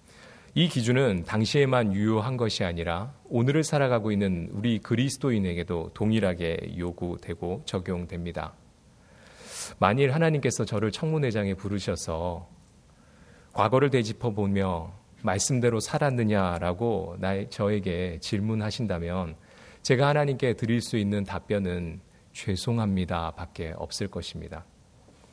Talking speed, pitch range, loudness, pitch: 285 characters per minute, 90-120 Hz, -27 LUFS, 100 Hz